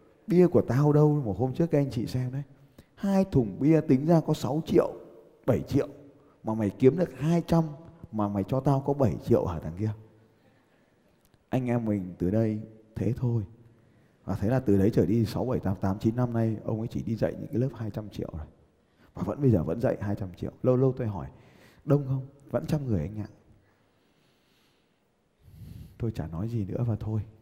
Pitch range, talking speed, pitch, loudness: 105-135 Hz, 210 wpm, 115 Hz, -28 LUFS